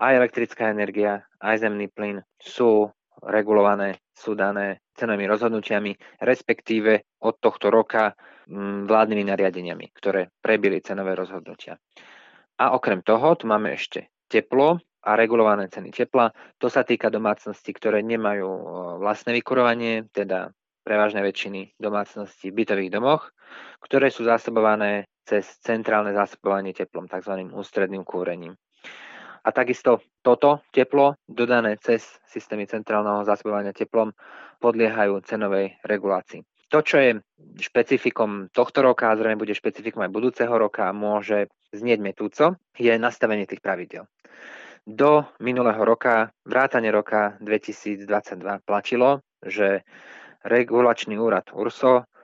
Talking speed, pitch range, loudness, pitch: 115 wpm, 100-115 Hz, -23 LUFS, 105 Hz